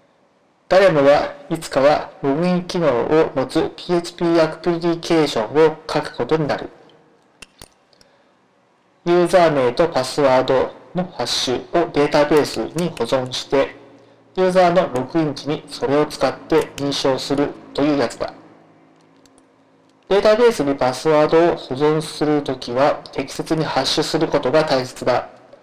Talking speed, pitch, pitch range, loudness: 295 characters per minute, 150 Hz, 135-170 Hz, -18 LUFS